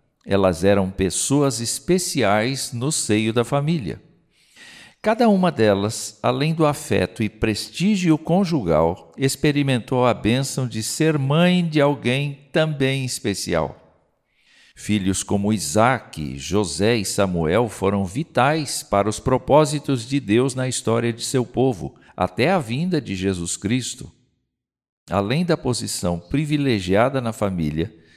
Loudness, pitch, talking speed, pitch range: -21 LUFS, 125 Hz, 120 wpm, 100-145 Hz